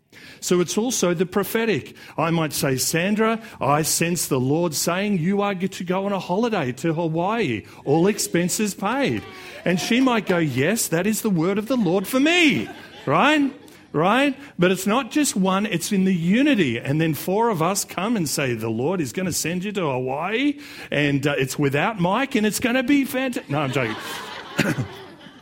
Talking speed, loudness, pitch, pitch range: 195 wpm, -21 LUFS, 190 Hz, 160-225 Hz